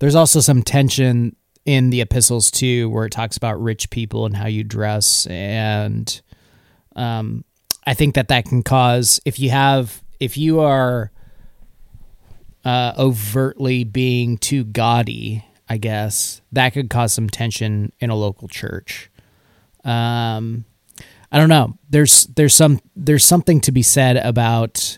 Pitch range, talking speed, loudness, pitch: 110-135 Hz, 145 wpm, -16 LUFS, 120 Hz